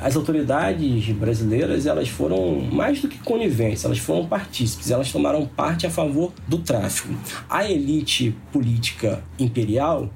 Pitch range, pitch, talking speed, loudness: 110-155 Hz, 125 Hz, 135 wpm, -22 LUFS